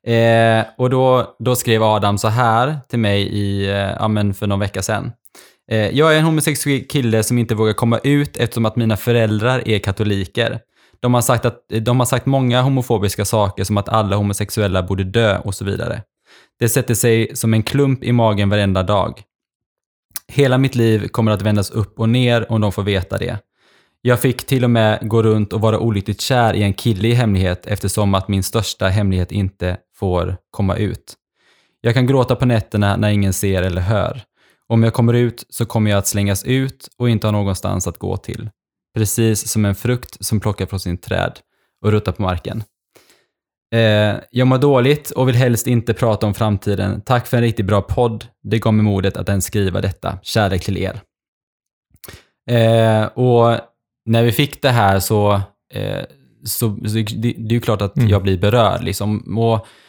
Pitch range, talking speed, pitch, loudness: 100-120 Hz, 195 wpm, 110 Hz, -17 LUFS